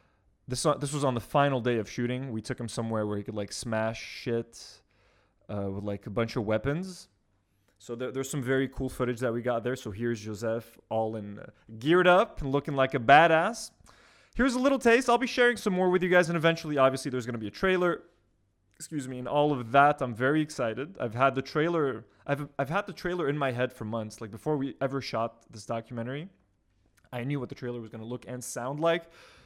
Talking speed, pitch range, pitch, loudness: 230 wpm, 110-145 Hz, 125 Hz, -28 LUFS